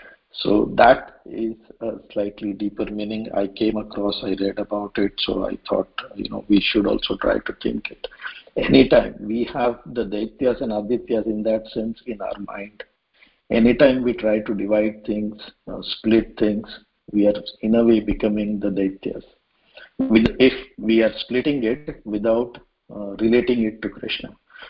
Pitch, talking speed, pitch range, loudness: 110 Hz, 170 wpm, 105-115 Hz, -21 LUFS